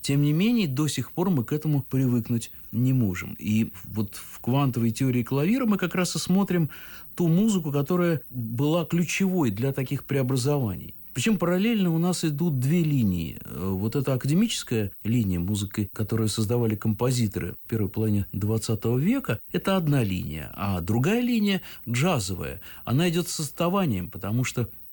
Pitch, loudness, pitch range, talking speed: 130 Hz, -26 LUFS, 110-170 Hz, 155 wpm